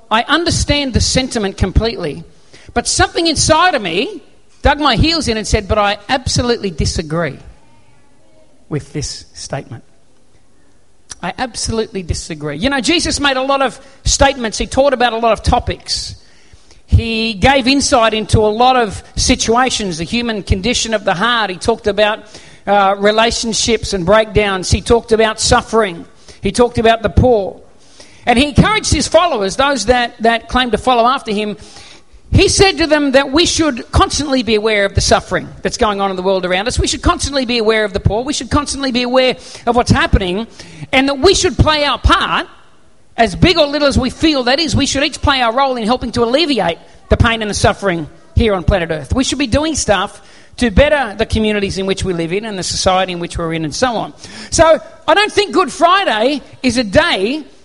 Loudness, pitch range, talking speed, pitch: -14 LUFS, 210-275 Hz, 195 wpm, 240 Hz